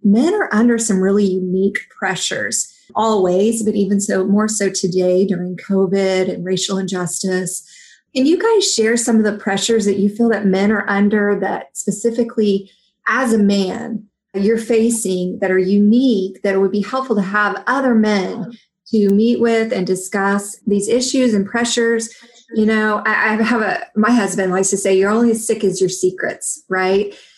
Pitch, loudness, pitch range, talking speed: 205 Hz, -16 LUFS, 195-230 Hz, 175 wpm